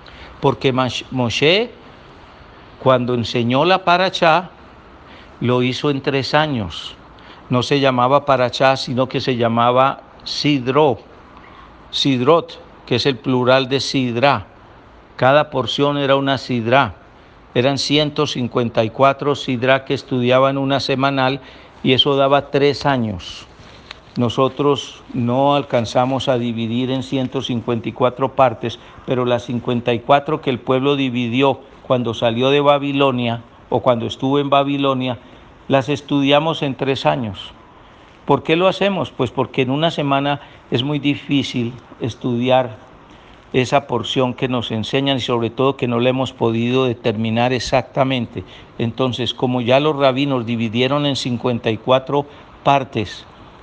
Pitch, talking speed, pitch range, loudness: 130 Hz, 125 wpm, 120-140 Hz, -18 LUFS